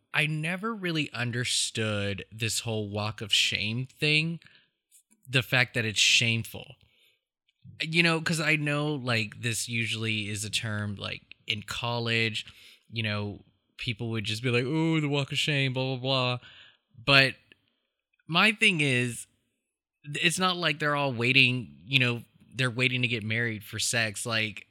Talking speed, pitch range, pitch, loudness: 155 wpm, 110-145 Hz, 120 Hz, -26 LUFS